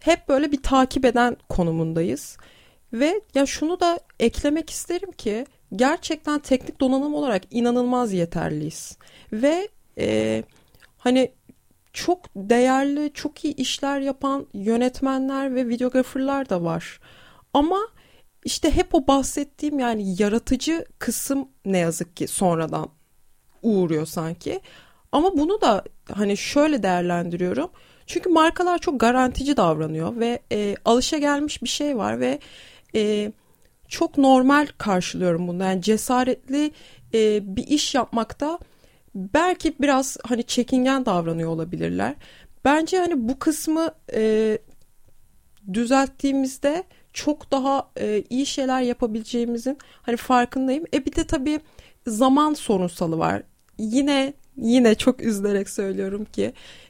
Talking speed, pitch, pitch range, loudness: 115 wpm, 260 Hz, 215-295 Hz, -23 LUFS